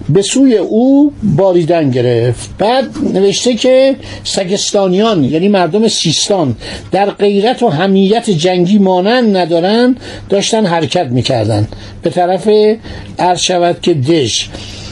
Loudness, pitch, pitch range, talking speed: -11 LUFS, 190 Hz, 160-215 Hz, 115 wpm